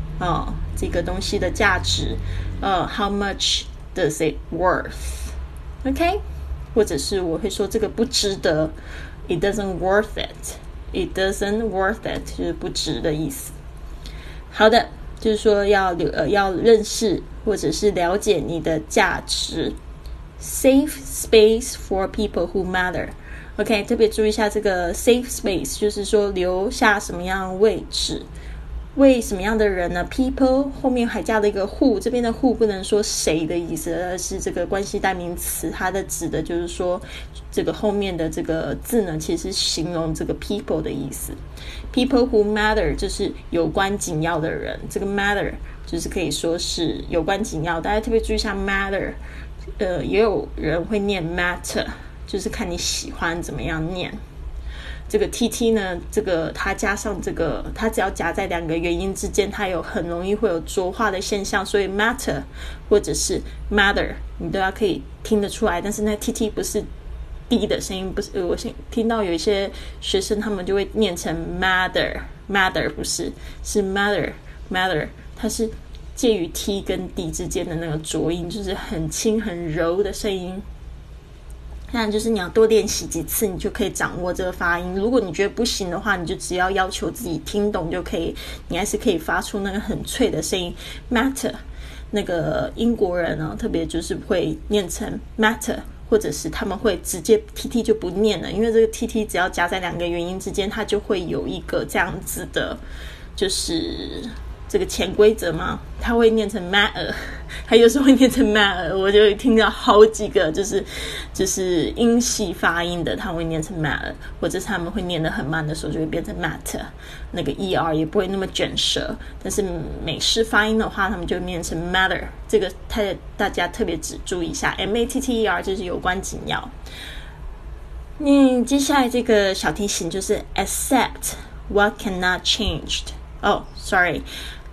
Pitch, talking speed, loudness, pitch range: 195 Hz, 335 characters per minute, -21 LUFS, 170-215 Hz